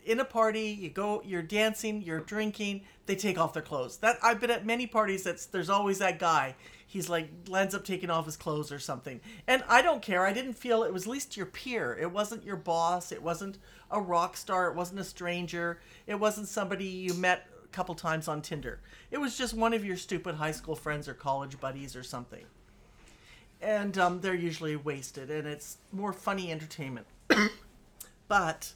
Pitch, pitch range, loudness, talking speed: 185 Hz, 160-210 Hz, -31 LUFS, 200 wpm